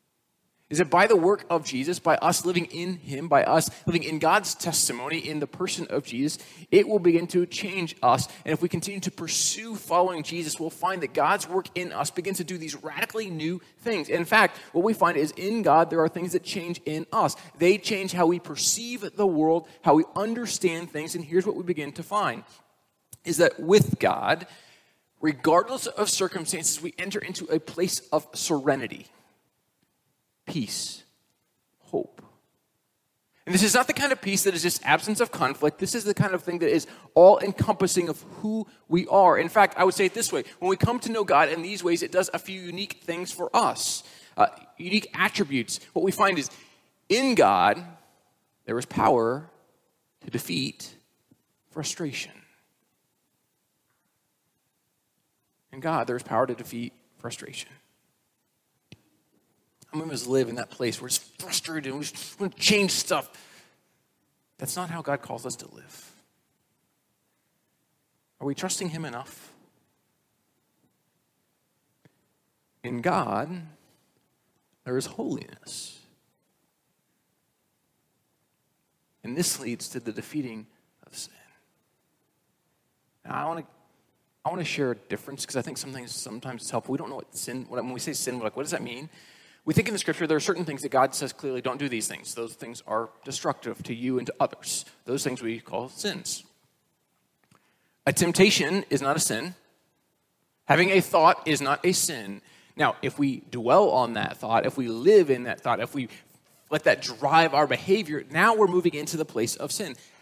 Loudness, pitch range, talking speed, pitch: -25 LUFS, 140-185 Hz, 175 wpm, 165 Hz